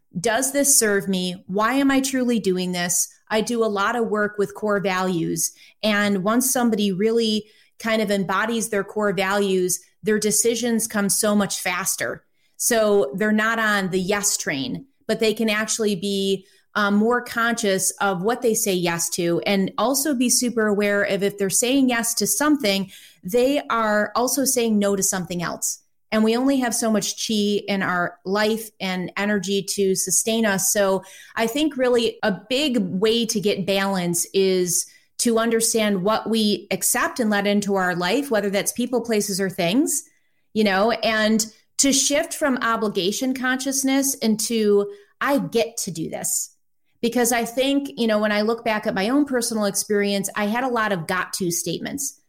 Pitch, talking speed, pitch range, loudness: 215 Hz, 175 wpm, 195-235 Hz, -21 LUFS